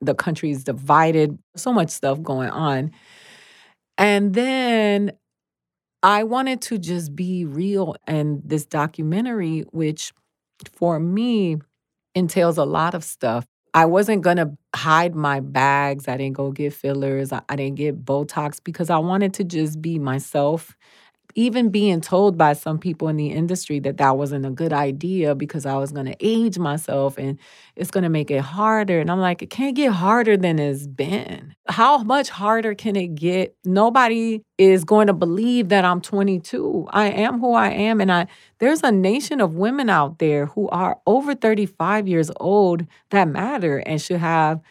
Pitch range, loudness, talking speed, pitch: 145-205 Hz, -20 LUFS, 175 wpm, 170 Hz